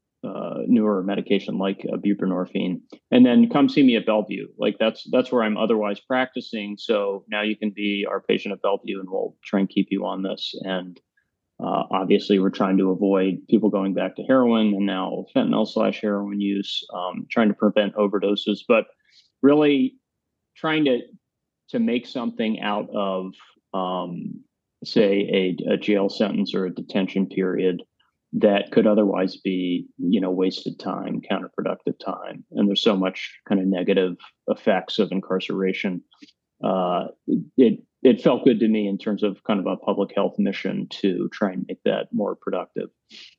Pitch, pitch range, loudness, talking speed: 100 Hz, 95-110 Hz, -23 LUFS, 170 wpm